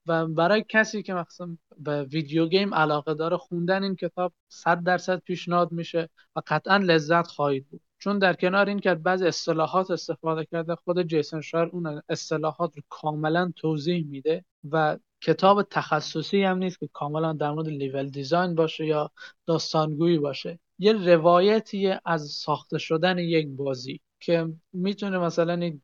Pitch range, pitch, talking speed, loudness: 155-180 Hz, 170 Hz, 150 wpm, -25 LUFS